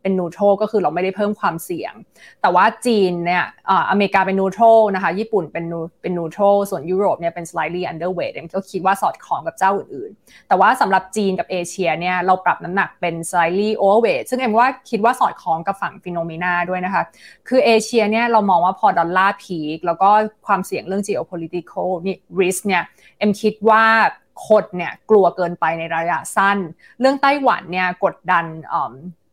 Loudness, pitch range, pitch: -18 LUFS, 175-210 Hz, 190 Hz